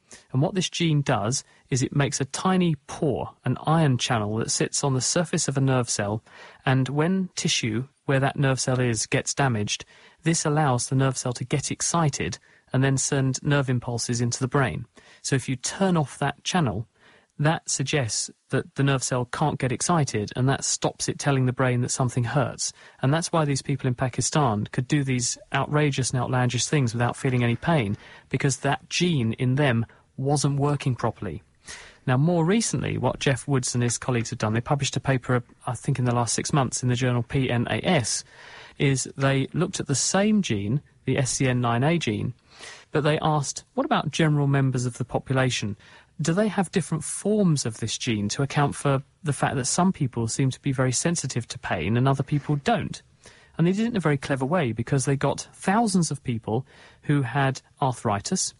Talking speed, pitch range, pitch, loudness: 195 wpm, 125-150 Hz, 135 Hz, -25 LUFS